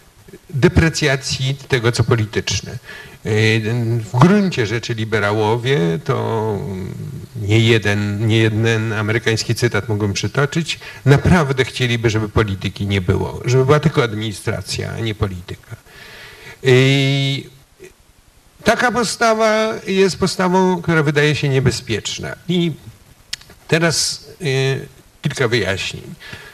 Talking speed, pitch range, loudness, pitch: 95 wpm, 110-150 Hz, -17 LUFS, 125 Hz